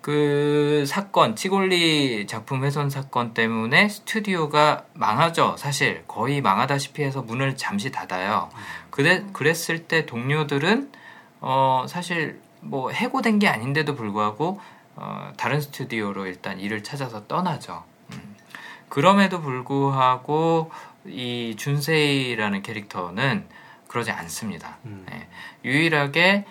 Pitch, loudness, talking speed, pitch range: 145 Hz, -23 LUFS, 260 characters per minute, 125-165 Hz